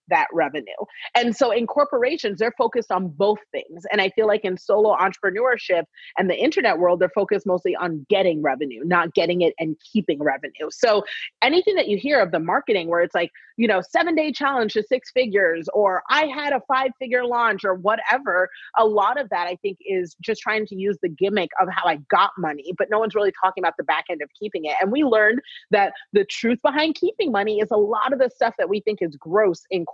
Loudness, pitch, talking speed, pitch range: -21 LUFS, 210 Hz, 225 wpm, 180-240 Hz